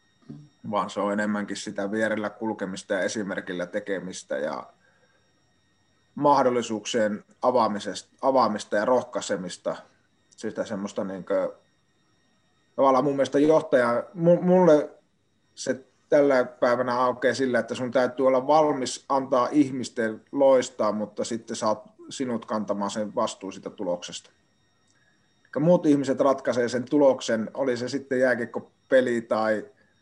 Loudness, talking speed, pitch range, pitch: -25 LUFS, 120 wpm, 105-135 Hz, 120 Hz